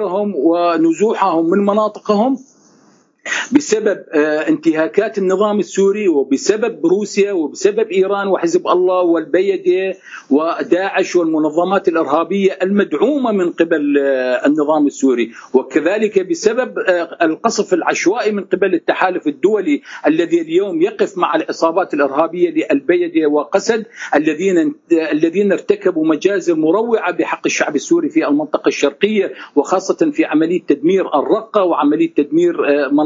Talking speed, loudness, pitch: 100 wpm, -15 LUFS, 195 Hz